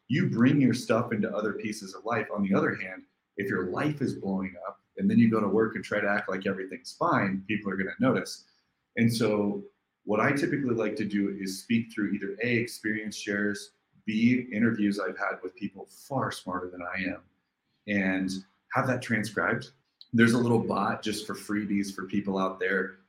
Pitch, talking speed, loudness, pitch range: 100 Hz, 205 wpm, -28 LUFS, 95-110 Hz